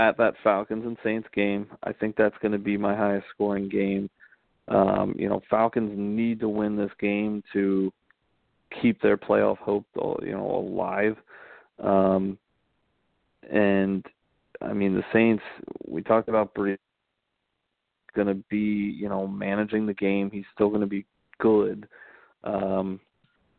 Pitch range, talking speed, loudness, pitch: 100-105 Hz, 140 wpm, -26 LUFS, 100 Hz